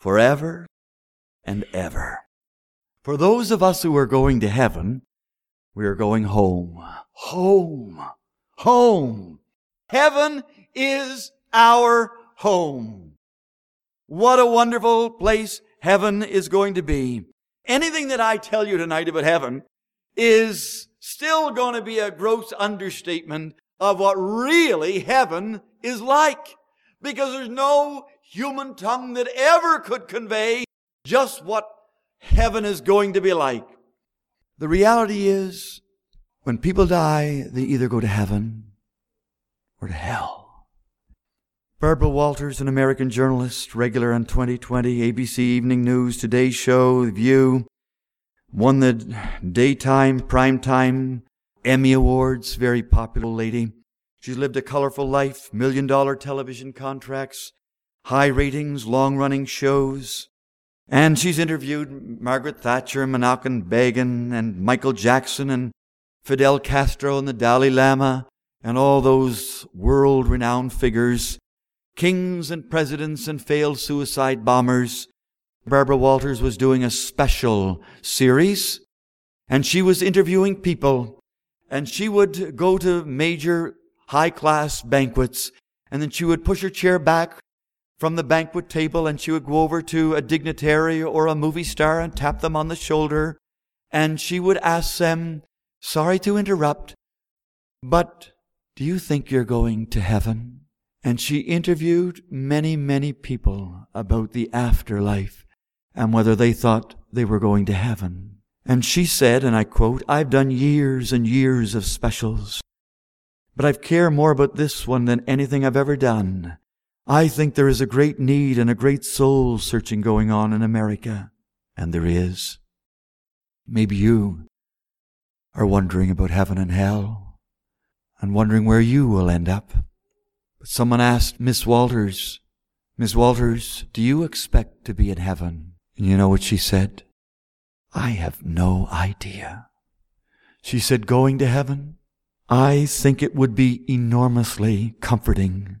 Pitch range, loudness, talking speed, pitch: 115-170 Hz, -20 LUFS, 135 wpm, 135 Hz